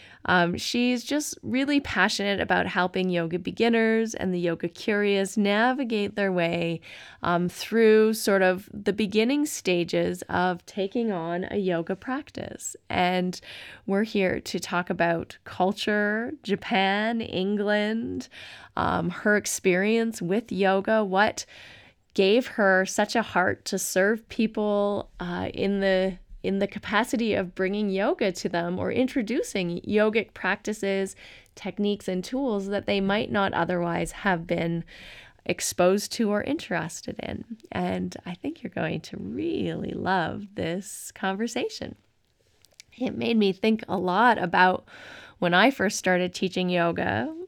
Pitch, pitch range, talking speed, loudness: 200 Hz, 180-220 Hz, 135 wpm, -26 LUFS